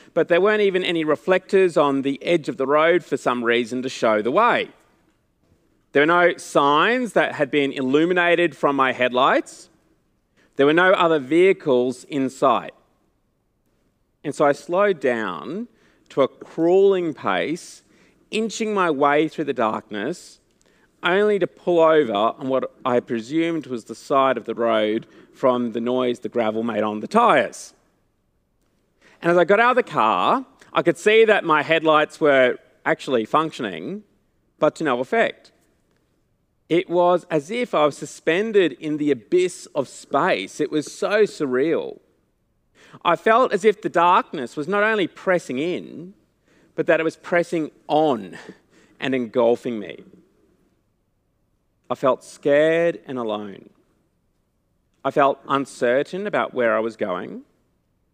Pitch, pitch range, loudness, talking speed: 155 Hz, 130-180 Hz, -20 LUFS, 150 wpm